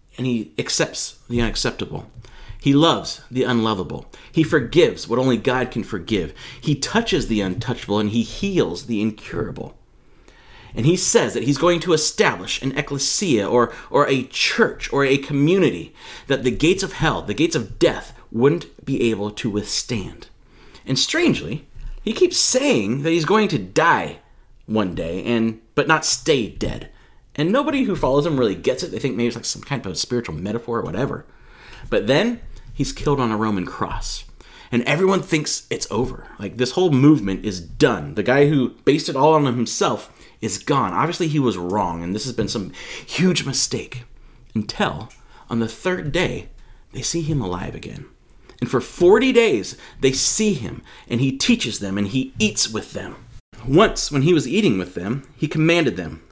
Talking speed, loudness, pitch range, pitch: 180 wpm, -20 LUFS, 110-155 Hz, 125 Hz